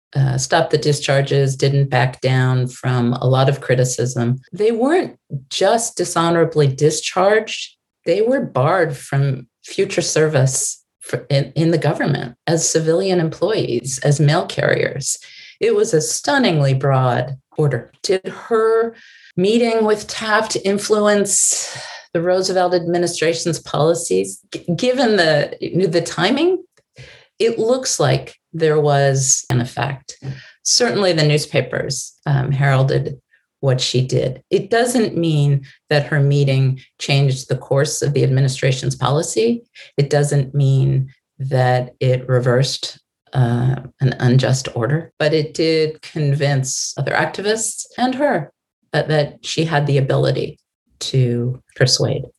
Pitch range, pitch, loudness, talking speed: 135-180 Hz, 150 Hz, -17 LUFS, 125 wpm